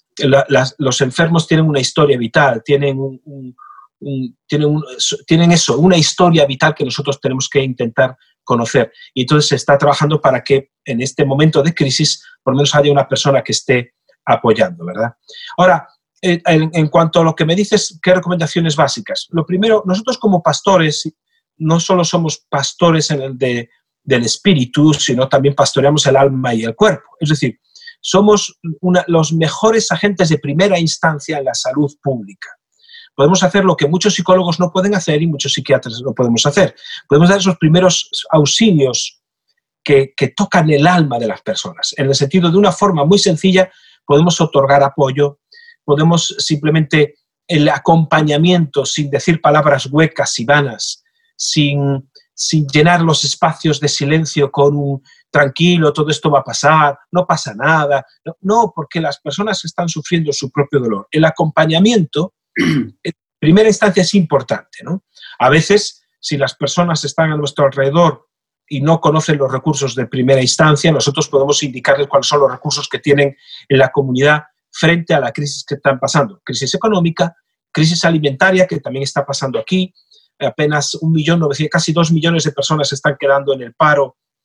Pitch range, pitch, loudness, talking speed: 140-175 Hz, 150 Hz, -14 LUFS, 170 wpm